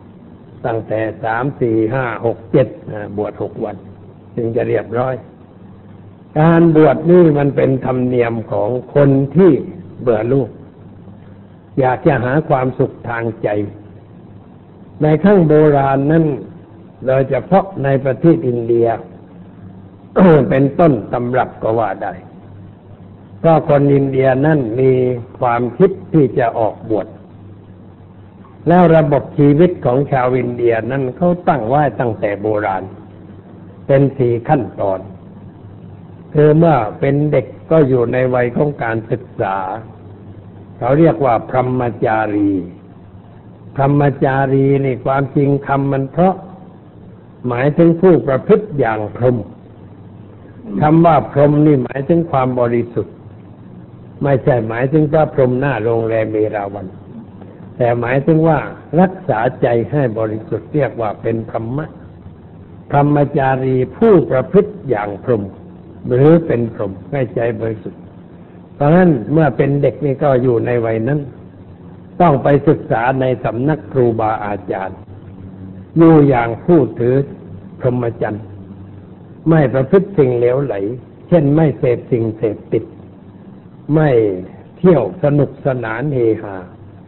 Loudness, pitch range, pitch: -15 LUFS, 100-145 Hz, 125 Hz